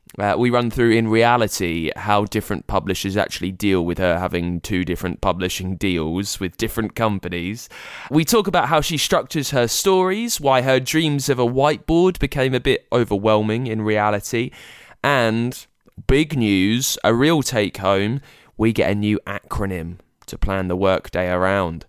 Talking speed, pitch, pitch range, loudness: 160 wpm, 110 Hz, 95-130 Hz, -20 LUFS